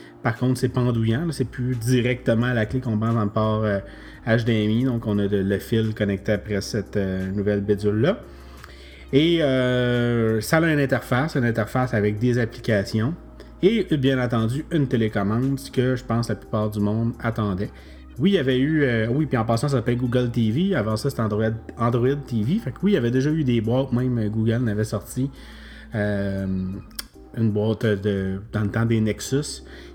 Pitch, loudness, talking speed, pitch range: 115 Hz, -23 LUFS, 190 wpm, 105-130 Hz